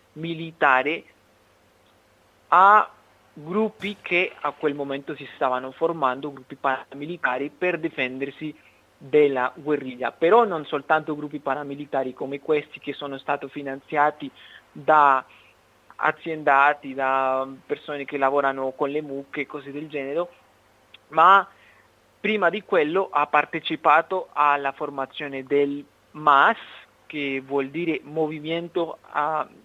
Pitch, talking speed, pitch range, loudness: 145 Hz, 110 wpm, 135-160 Hz, -23 LUFS